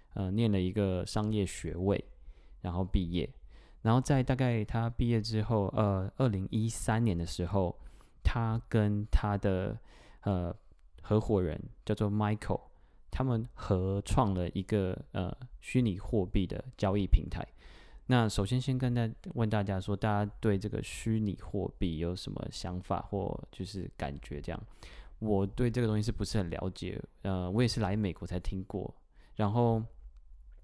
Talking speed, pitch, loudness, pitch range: 240 characters per minute, 100 Hz, -33 LUFS, 90-110 Hz